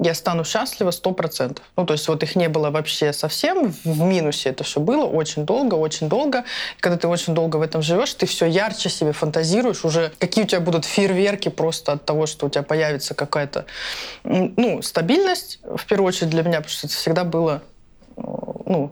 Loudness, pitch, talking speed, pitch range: -21 LUFS, 165 Hz, 200 wpm, 155-185 Hz